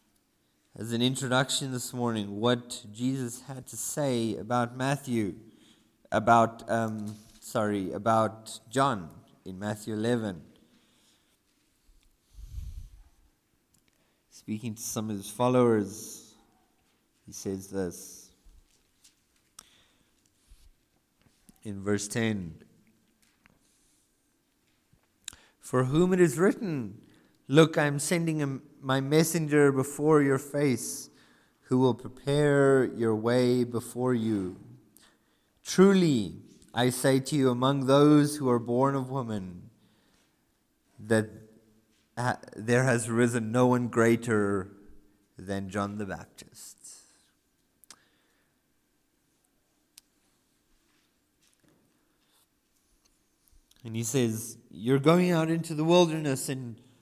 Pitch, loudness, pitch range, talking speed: 120 Hz, -27 LUFS, 105-135 Hz, 95 wpm